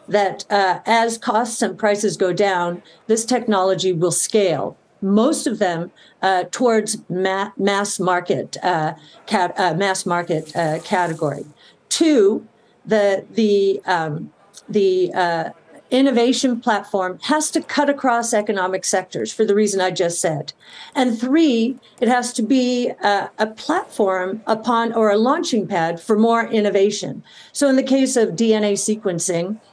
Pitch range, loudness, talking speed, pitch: 185-235 Hz, -19 LUFS, 145 wpm, 205 Hz